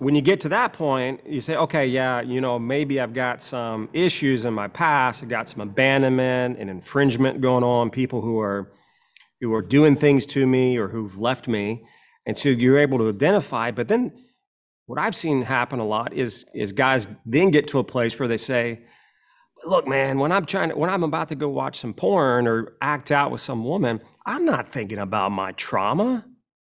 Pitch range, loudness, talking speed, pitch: 115-145 Hz, -22 LUFS, 205 wpm, 130 Hz